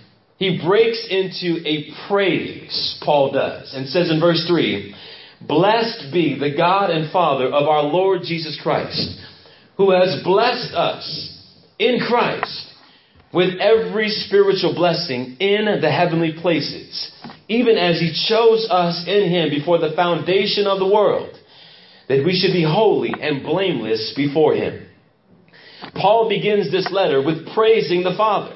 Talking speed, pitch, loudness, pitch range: 140 wpm, 180 Hz, -18 LUFS, 155-200 Hz